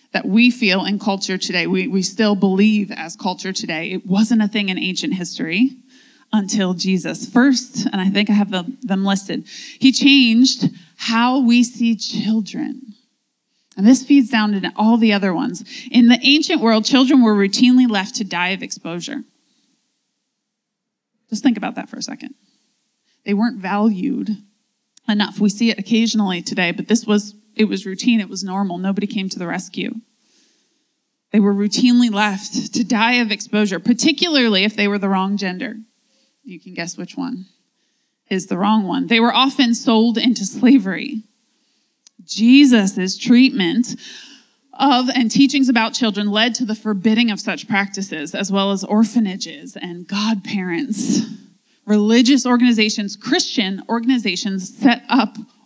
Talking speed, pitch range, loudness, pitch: 155 wpm, 200-250 Hz, -17 LUFS, 225 Hz